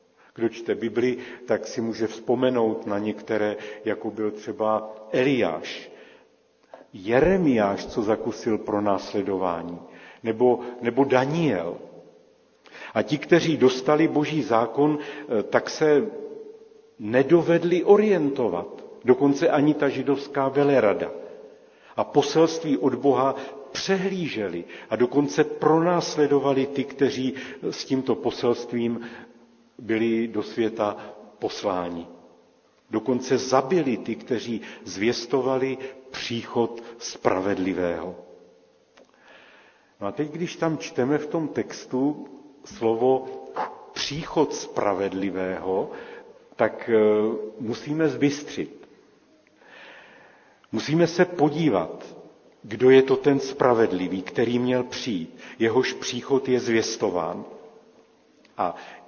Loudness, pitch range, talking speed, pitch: -24 LUFS, 115-150 Hz, 90 wpm, 130 Hz